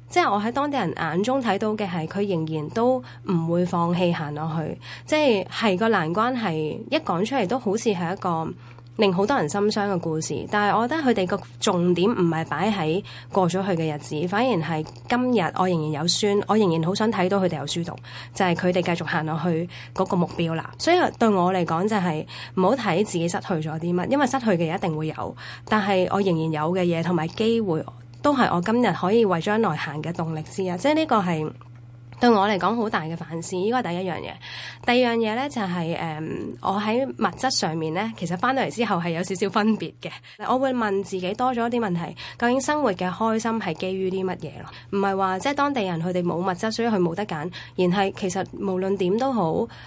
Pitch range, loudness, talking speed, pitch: 165-220 Hz, -23 LUFS, 320 characters per minute, 190 Hz